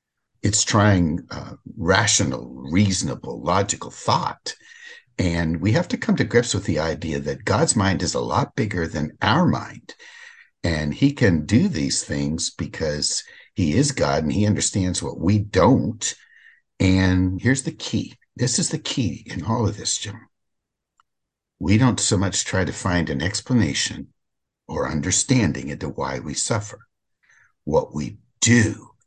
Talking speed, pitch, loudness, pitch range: 155 wpm, 100 Hz, -21 LUFS, 85-120 Hz